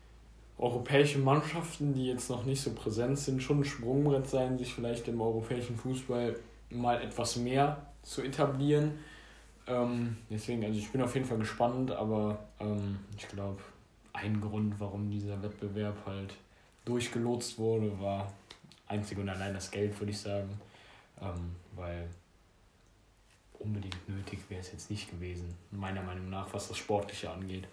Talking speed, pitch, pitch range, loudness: 150 wpm, 105 Hz, 100-120 Hz, -35 LUFS